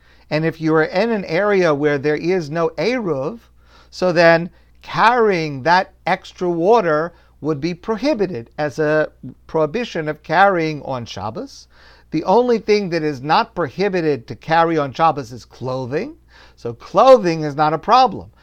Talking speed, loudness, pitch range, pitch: 155 wpm, -18 LUFS, 150-190 Hz, 160 Hz